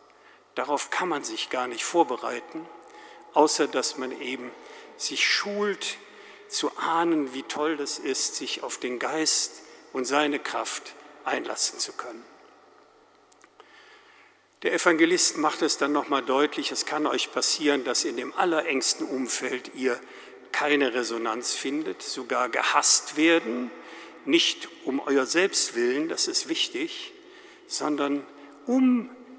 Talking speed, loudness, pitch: 125 wpm, -25 LUFS, 355 Hz